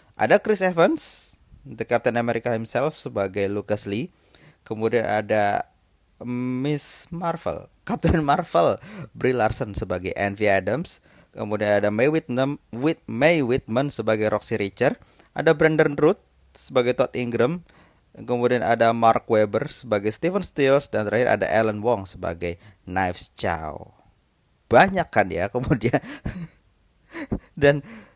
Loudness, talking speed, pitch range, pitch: -22 LUFS, 120 wpm, 105-140 Hz, 115 Hz